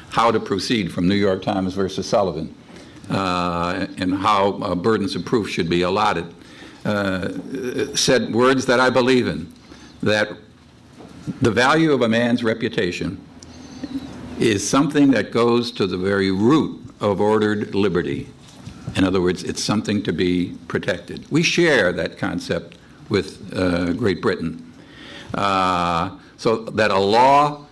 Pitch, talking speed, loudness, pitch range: 105 Hz, 140 wpm, -20 LUFS, 95-130 Hz